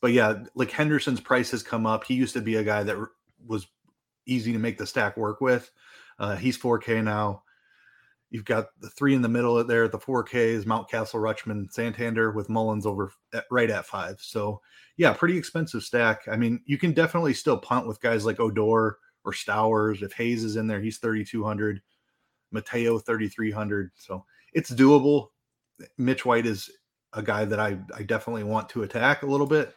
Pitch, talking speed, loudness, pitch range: 115 Hz, 190 wpm, -26 LUFS, 110-125 Hz